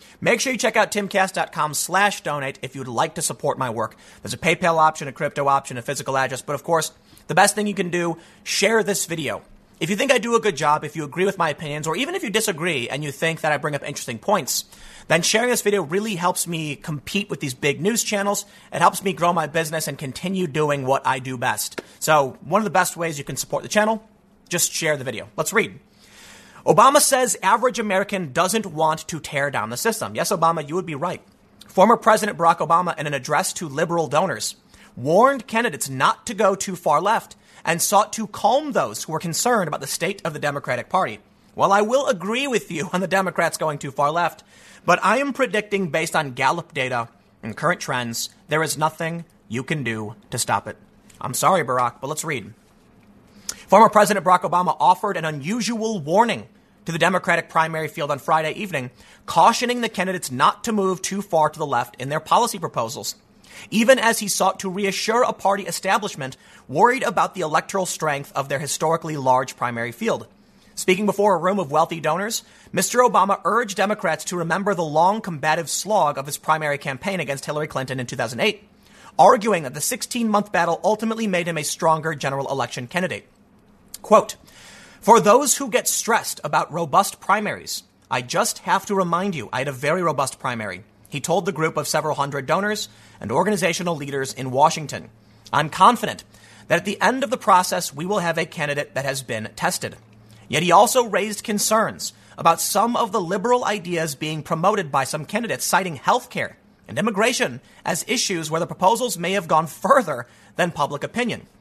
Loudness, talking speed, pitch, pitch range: -21 LUFS, 200 wpm, 170 Hz, 145-205 Hz